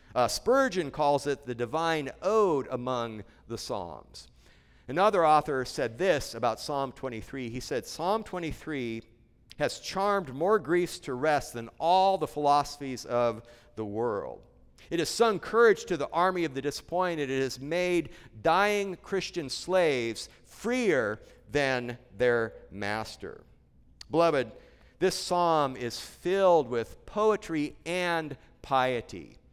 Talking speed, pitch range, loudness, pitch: 130 wpm, 120-175 Hz, -29 LUFS, 145 Hz